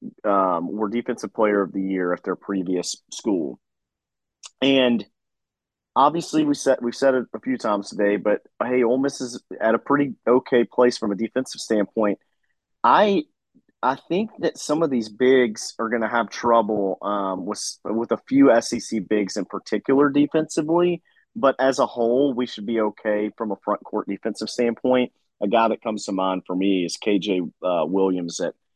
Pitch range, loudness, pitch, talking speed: 105-130 Hz, -22 LUFS, 115 Hz, 180 wpm